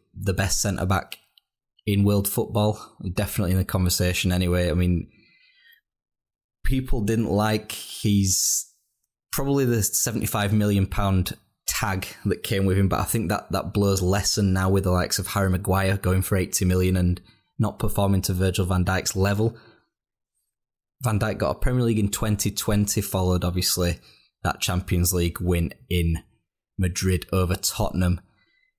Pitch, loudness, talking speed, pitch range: 95 Hz, -24 LUFS, 155 wpm, 90-105 Hz